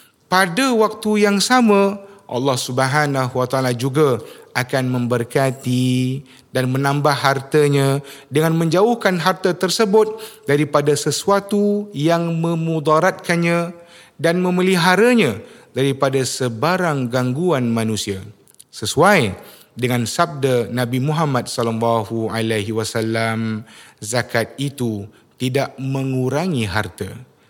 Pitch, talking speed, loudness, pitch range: 140 Hz, 90 wpm, -18 LUFS, 125-175 Hz